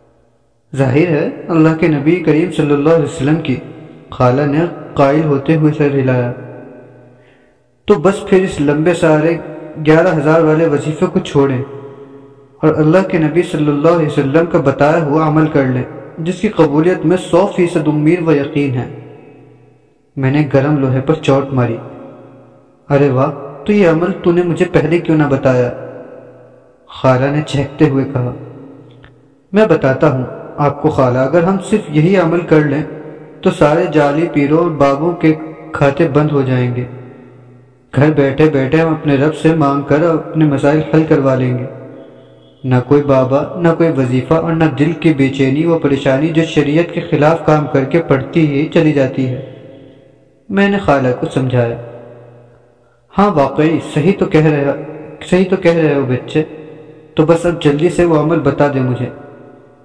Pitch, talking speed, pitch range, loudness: 150 Hz, 170 wpm, 135-160 Hz, -13 LUFS